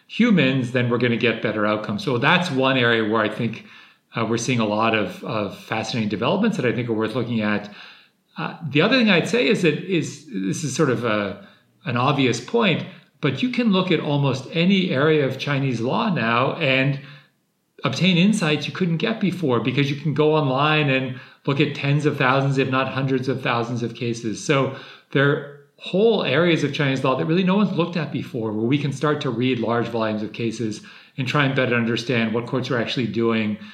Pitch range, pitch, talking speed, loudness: 120-155 Hz, 135 Hz, 215 wpm, -21 LUFS